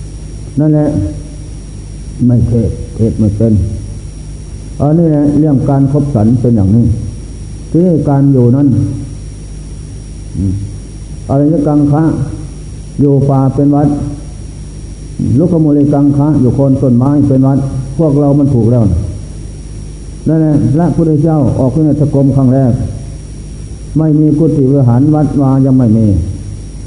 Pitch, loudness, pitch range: 135 Hz, -10 LUFS, 115-145 Hz